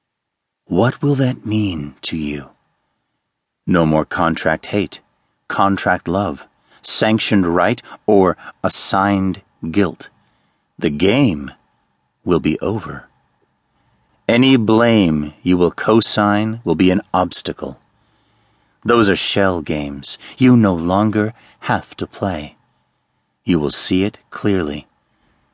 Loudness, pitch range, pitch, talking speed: -17 LUFS, 85-110 Hz, 95 Hz, 110 wpm